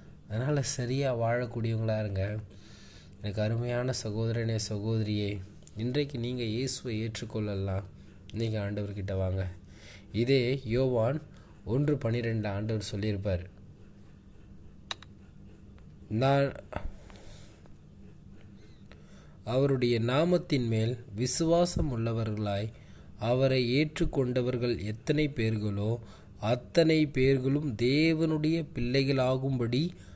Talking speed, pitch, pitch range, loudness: 70 wpm, 115 Hz, 100-130 Hz, -30 LUFS